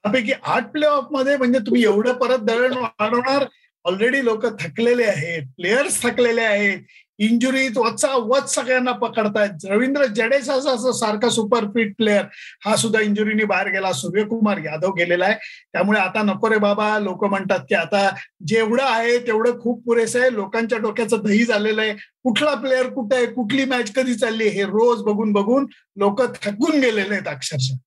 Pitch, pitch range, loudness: 225 Hz, 205-255 Hz, -19 LUFS